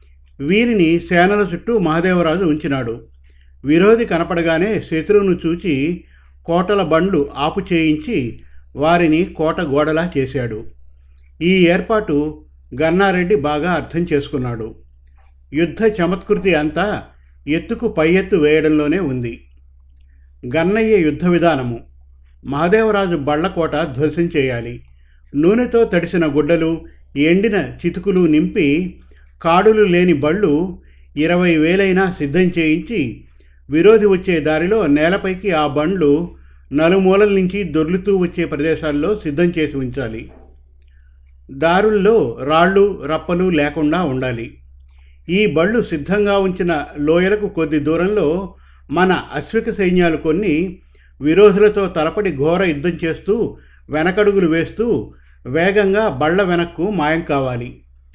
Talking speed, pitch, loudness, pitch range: 95 wpm, 160 Hz, -16 LUFS, 130-185 Hz